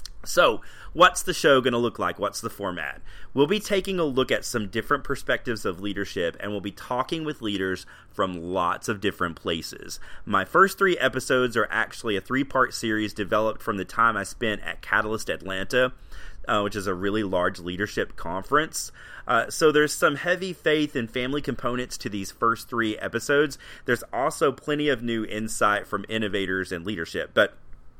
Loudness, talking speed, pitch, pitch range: -25 LUFS, 180 wpm, 115 Hz, 100-140 Hz